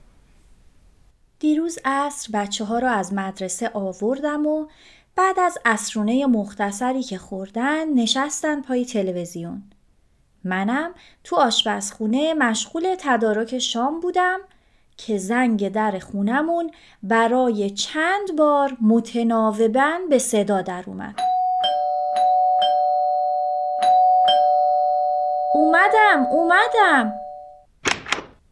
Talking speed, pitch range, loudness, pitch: 80 wpm, 195-295 Hz, -20 LUFS, 230 Hz